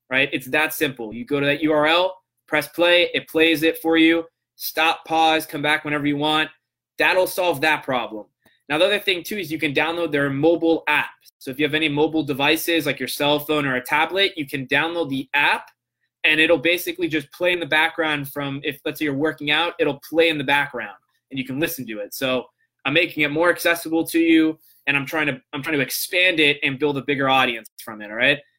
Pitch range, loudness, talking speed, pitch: 140-165 Hz, -20 LUFS, 230 wpm, 155 Hz